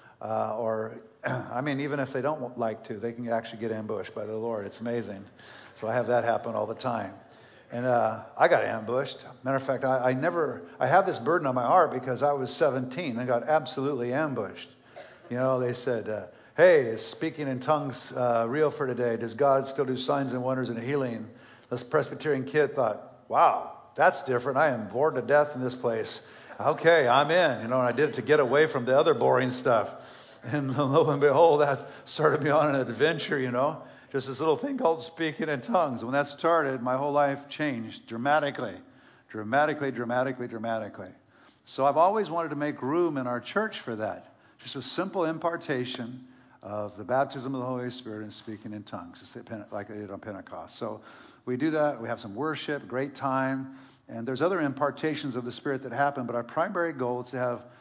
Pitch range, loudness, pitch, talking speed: 120-145 Hz, -27 LUFS, 130 Hz, 205 wpm